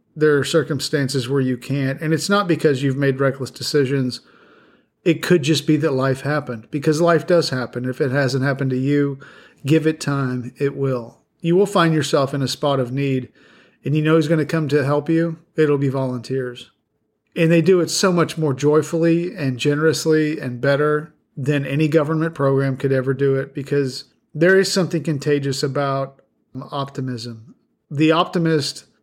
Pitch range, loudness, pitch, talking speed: 135-160 Hz, -19 LUFS, 145 Hz, 180 wpm